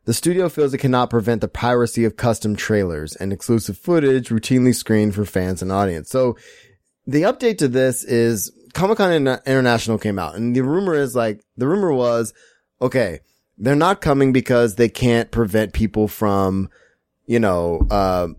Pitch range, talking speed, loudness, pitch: 105-130 Hz, 175 wpm, -19 LUFS, 115 Hz